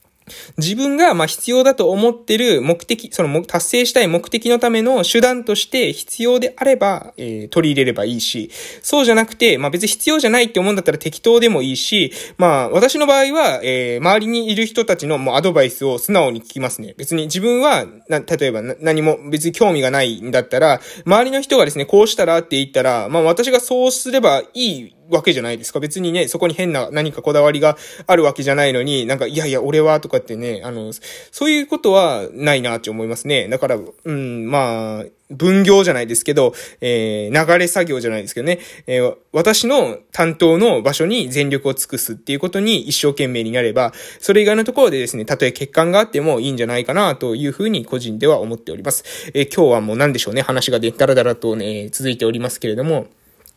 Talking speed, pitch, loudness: 415 characters per minute, 160 Hz, -16 LUFS